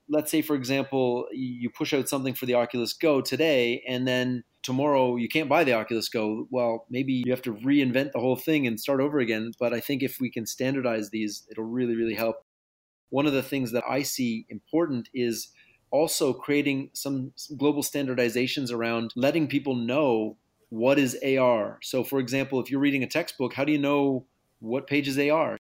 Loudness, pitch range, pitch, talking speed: -26 LUFS, 120-140 Hz, 130 Hz, 195 wpm